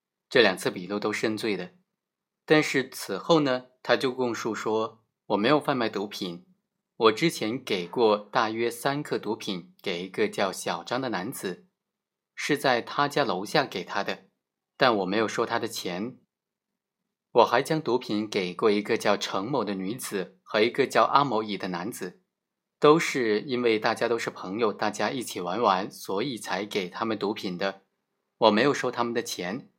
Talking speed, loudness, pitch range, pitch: 245 characters per minute, -27 LUFS, 110-155 Hz, 125 Hz